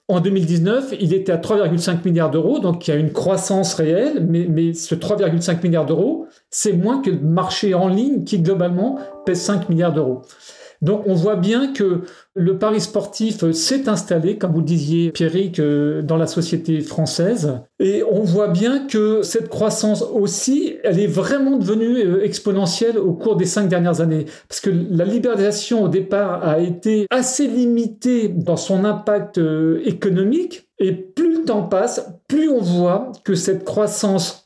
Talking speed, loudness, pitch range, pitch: 170 wpm, -18 LUFS, 170-215 Hz, 190 Hz